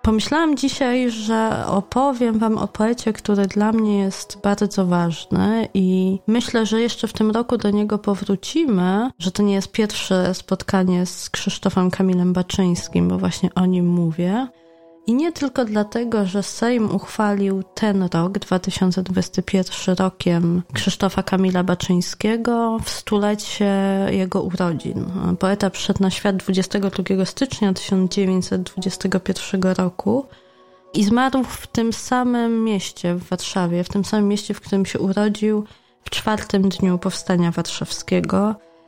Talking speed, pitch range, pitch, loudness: 130 wpm, 185-215 Hz, 195 Hz, -20 LUFS